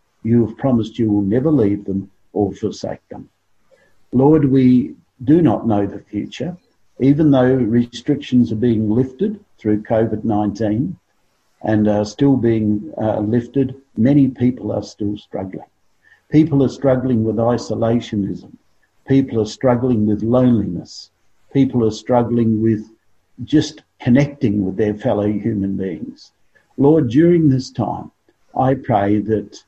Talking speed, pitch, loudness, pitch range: 135 wpm, 115 Hz, -17 LUFS, 105-130 Hz